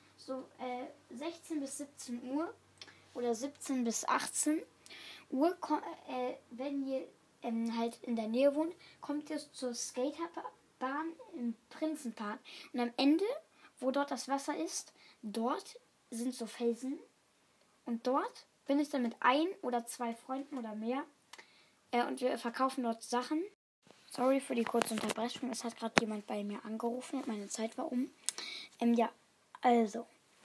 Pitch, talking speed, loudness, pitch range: 255 Hz, 150 wpm, -37 LUFS, 235-295 Hz